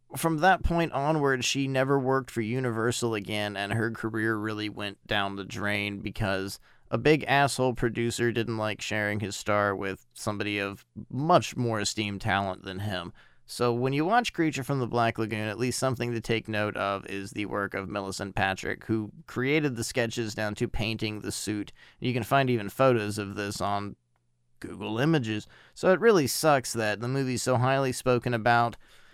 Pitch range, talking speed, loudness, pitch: 105-130 Hz, 185 wpm, -28 LUFS, 110 Hz